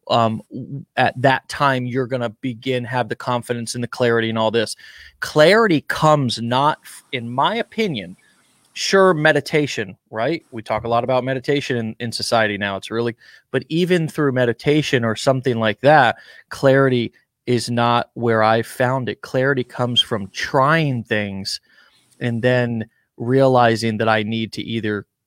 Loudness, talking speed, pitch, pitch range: -19 LUFS, 155 wpm, 120 Hz, 115-135 Hz